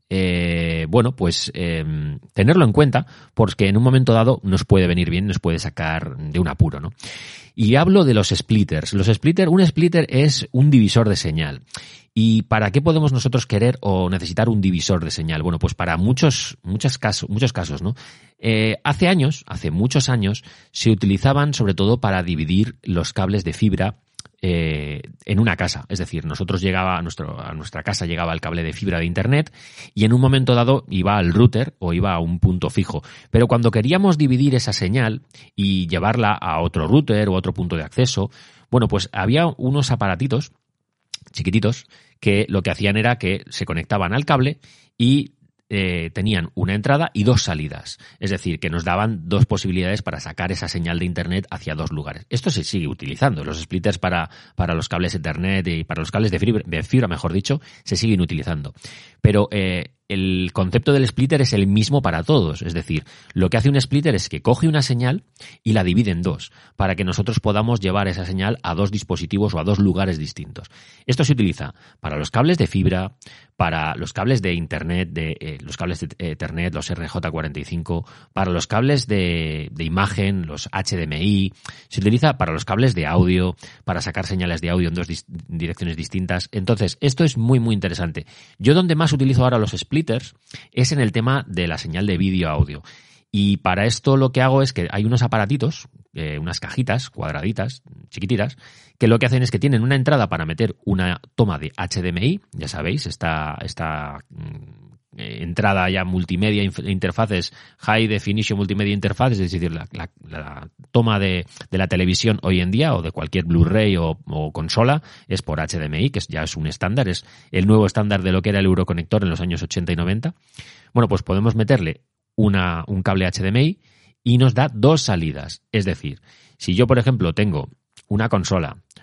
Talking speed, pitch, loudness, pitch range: 190 wpm, 100 Hz, -20 LUFS, 90-125 Hz